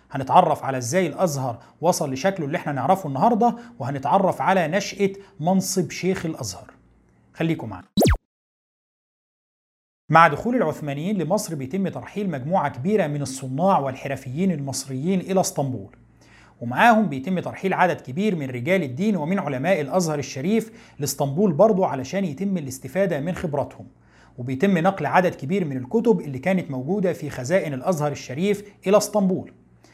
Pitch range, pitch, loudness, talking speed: 140-195 Hz, 175 Hz, -22 LUFS, 130 wpm